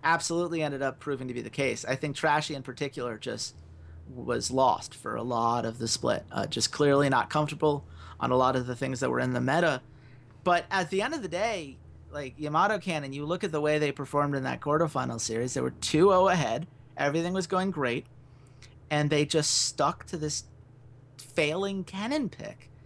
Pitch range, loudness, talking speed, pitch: 125-155 Hz, -28 LUFS, 200 wpm, 140 Hz